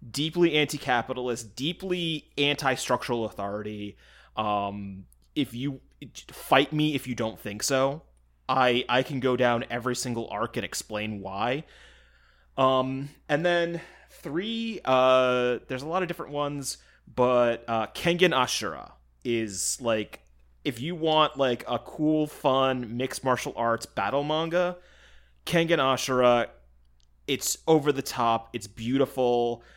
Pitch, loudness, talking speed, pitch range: 125 Hz, -27 LUFS, 125 wpm, 110-145 Hz